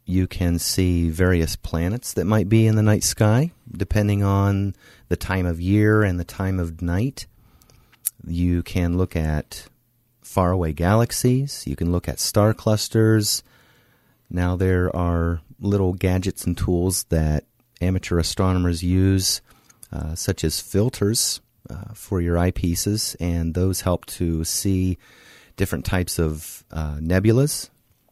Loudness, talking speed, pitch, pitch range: -22 LUFS, 135 wpm, 95 Hz, 85-105 Hz